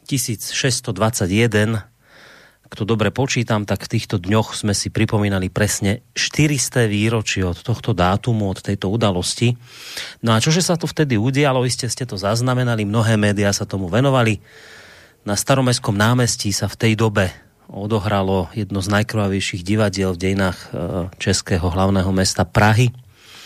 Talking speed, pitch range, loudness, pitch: 140 wpm, 100-120 Hz, -19 LUFS, 110 Hz